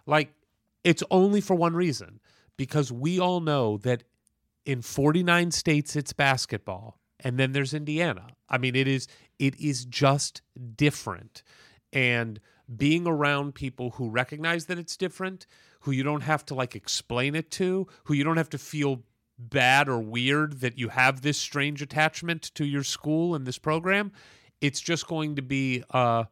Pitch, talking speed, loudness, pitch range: 140 Hz, 165 wpm, -26 LUFS, 125-155 Hz